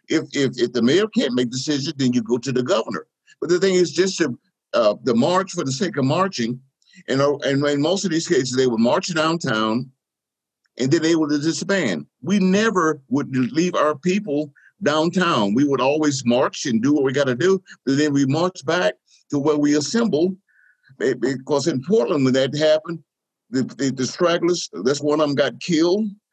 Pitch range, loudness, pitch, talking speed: 135-180 Hz, -20 LUFS, 155 Hz, 195 wpm